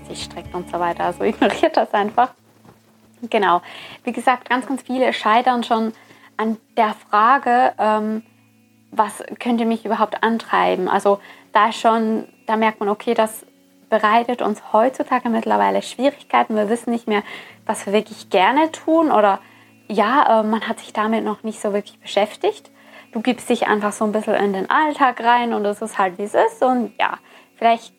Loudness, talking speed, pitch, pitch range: -19 LUFS, 175 wpm, 220 Hz, 205-245 Hz